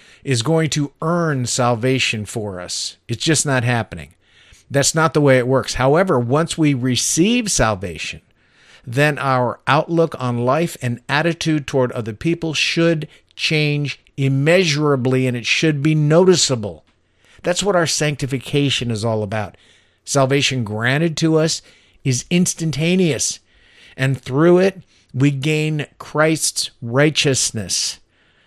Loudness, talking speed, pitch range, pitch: -18 LUFS, 125 wpm, 120-160 Hz, 140 Hz